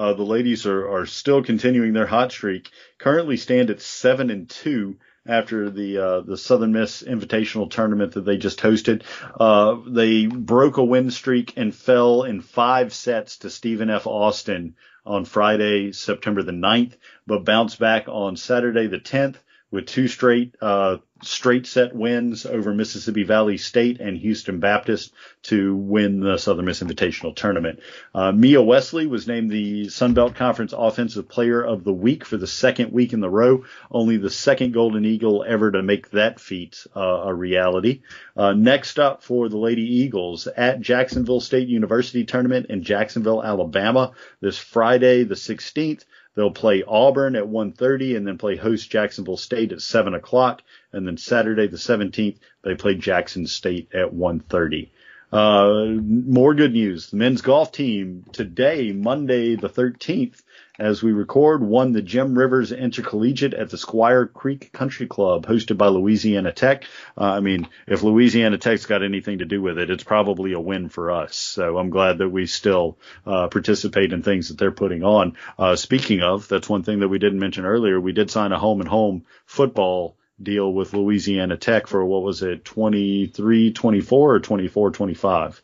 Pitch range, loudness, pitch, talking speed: 100-120 Hz, -20 LUFS, 110 Hz, 170 wpm